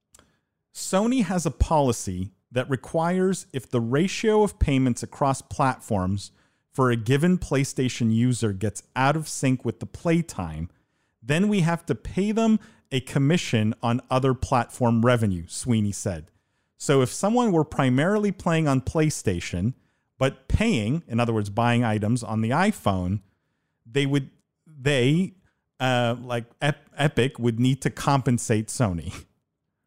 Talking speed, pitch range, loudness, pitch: 140 wpm, 110-150 Hz, -24 LUFS, 130 Hz